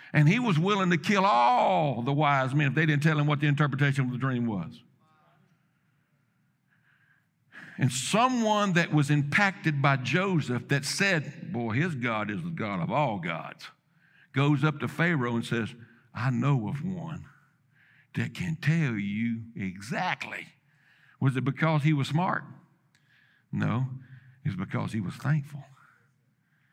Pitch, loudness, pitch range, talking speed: 145 Hz, -27 LUFS, 130-160 Hz, 150 wpm